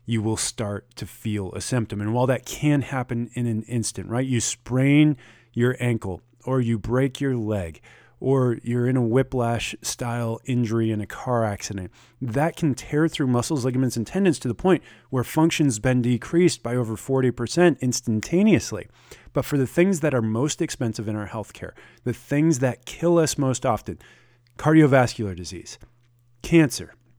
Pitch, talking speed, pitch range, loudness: 120 Hz, 170 wpm, 115-135 Hz, -23 LUFS